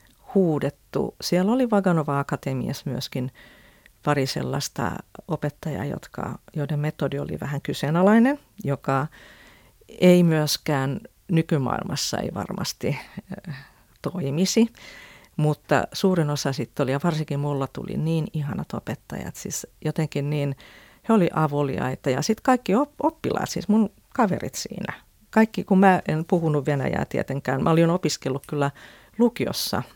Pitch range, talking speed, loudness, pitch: 140-185 Hz, 120 wpm, -24 LUFS, 155 Hz